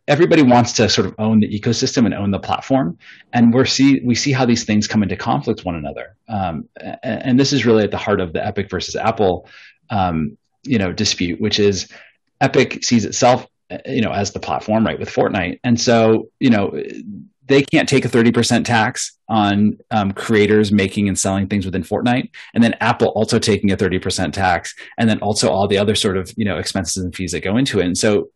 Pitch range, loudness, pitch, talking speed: 100-120 Hz, -17 LUFS, 110 Hz, 220 wpm